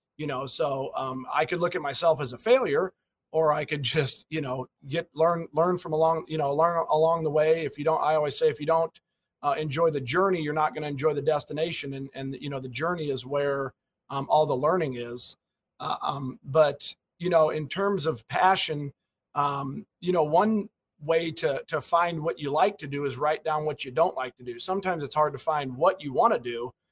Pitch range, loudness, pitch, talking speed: 140-165 Hz, -27 LUFS, 155 Hz, 230 wpm